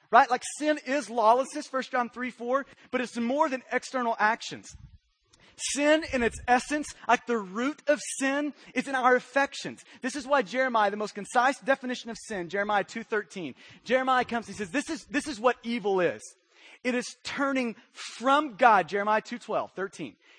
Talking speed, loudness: 180 wpm, -28 LUFS